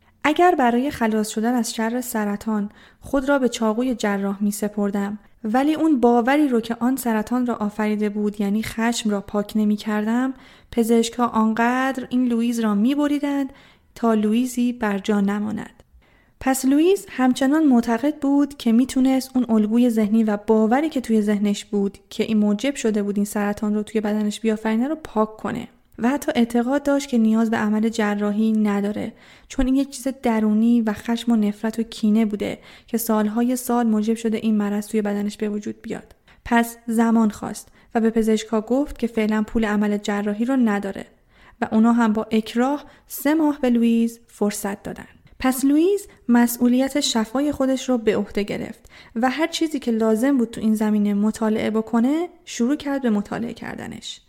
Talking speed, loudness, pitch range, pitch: 175 wpm, -21 LUFS, 215-255 Hz, 230 Hz